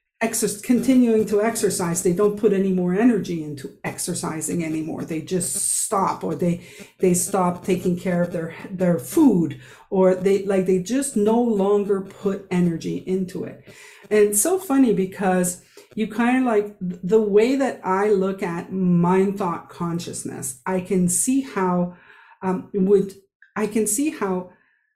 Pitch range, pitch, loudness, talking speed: 180-215 Hz, 195 Hz, -21 LUFS, 155 wpm